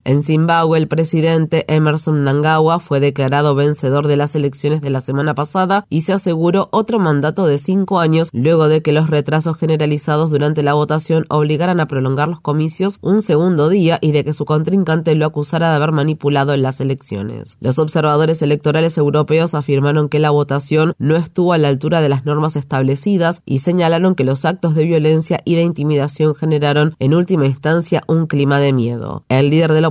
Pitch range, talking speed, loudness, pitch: 145-165 Hz, 185 wpm, -15 LUFS, 155 Hz